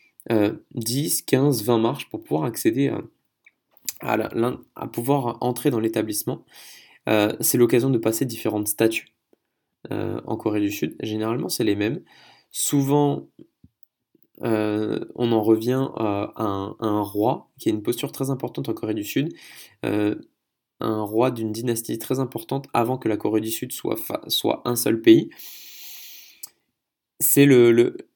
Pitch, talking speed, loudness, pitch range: 115 Hz, 160 wpm, -23 LUFS, 110-140 Hz